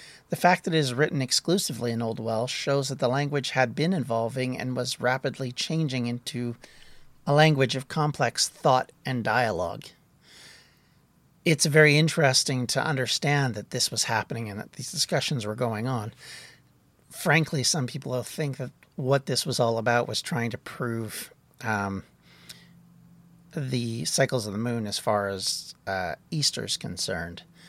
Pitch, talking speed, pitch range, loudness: 130 Hz, 160 wpm, 120-150 Hz, -26 LUFS